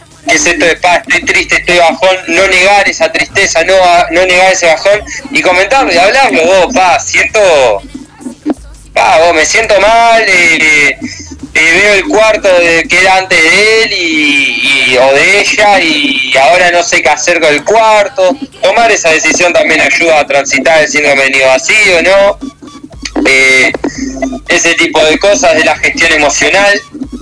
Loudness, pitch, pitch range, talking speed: -6 LUFS, 195 Hz, 165-260 Hz, 170 wpm